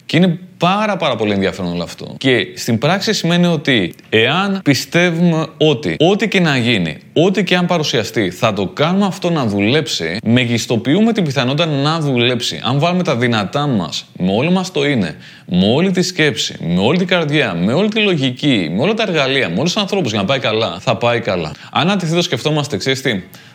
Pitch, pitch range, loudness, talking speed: 155 Hz, 130-180 Hz, -15 LUFS, 195 wpm